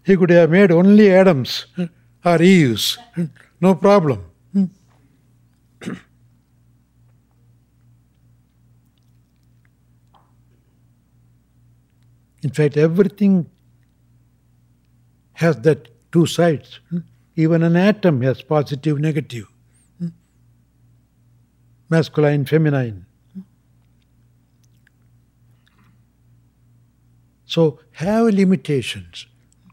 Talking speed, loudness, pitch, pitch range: 55 wpm, -17 LUFS, 120 Hz, 120-160 Hz